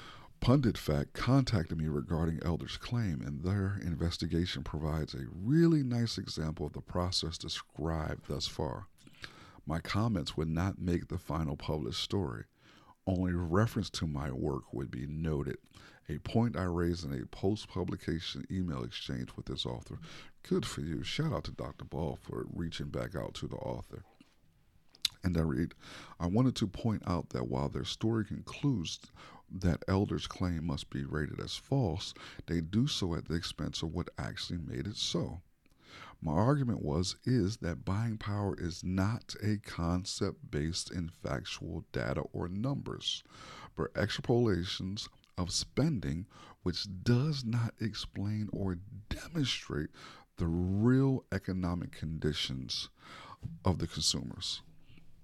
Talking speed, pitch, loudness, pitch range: 145 wpm, 90 Hz, -35 LUFS, 80-110 Hz